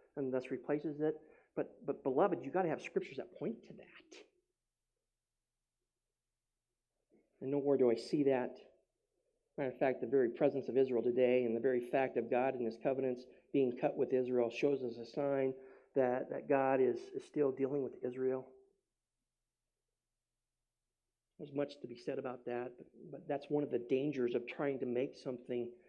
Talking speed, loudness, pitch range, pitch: 175 wpm, -37 LUFS, 125-145 Hz, 135 Hz